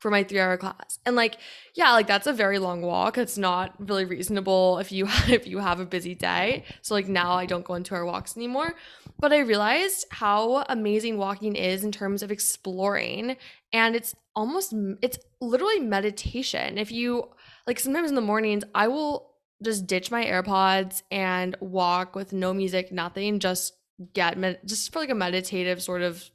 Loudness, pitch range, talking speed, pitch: -26 LUFS, 185-230 Hz, 180 wpm, 200 Hz